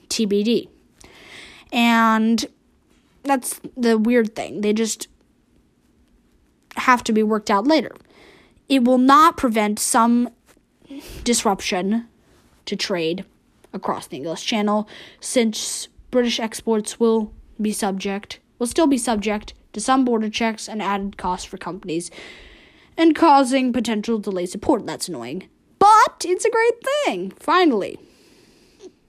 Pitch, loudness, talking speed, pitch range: 230 Hz, -20 LUFS, 120 wpm, 210-270 Hz